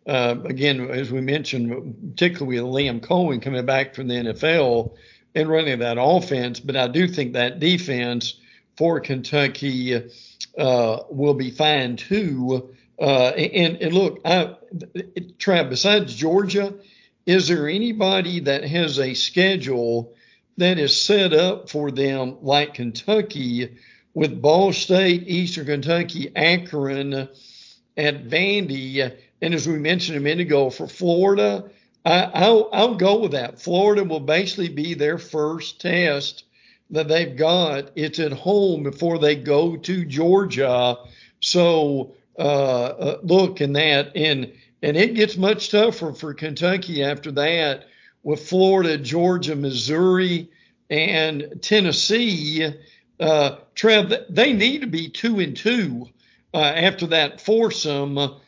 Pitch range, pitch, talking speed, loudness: 135-180 Hz, 155 Hz, 135 wpm, -20 LUFS